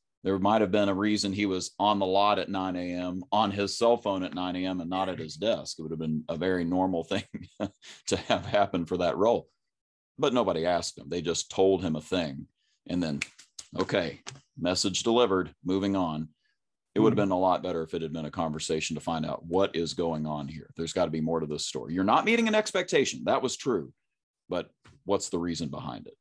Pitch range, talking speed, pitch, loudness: 80-100 Hz, 230 wpm, 95 Hz, -29 LUFS